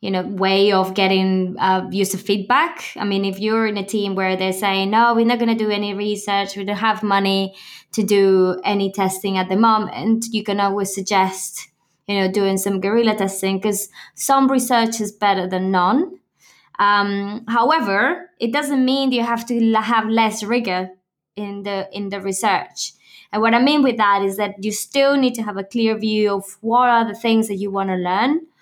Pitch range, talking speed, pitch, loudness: 195-230 Hz, 200 wpm, 205 Hz, -19 LUFS